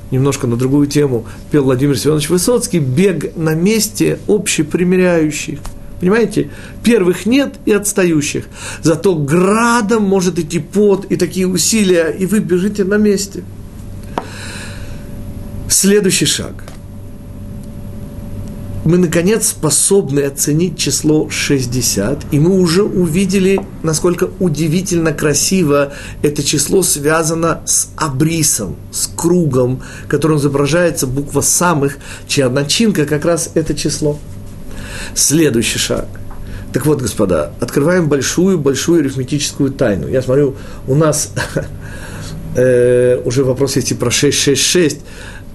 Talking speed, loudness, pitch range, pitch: 105 wpm, -13 LUFS, 120-180 Hz, 150 Hz